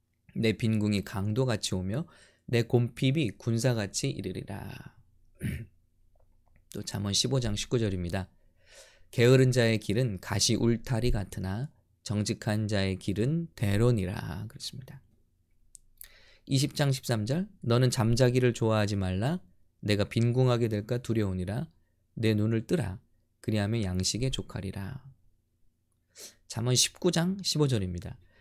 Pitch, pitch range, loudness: 110 Hz, 95-125 Hz, -29 LUFS